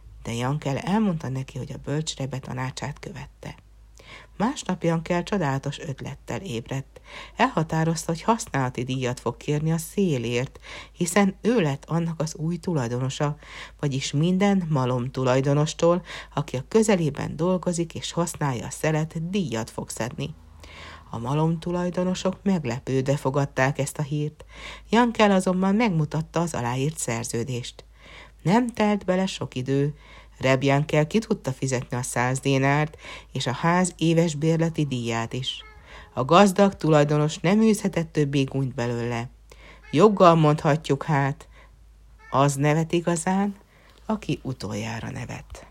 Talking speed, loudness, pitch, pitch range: 125 wpm, -24 LUFS, 150 Hz, 130-175 Hz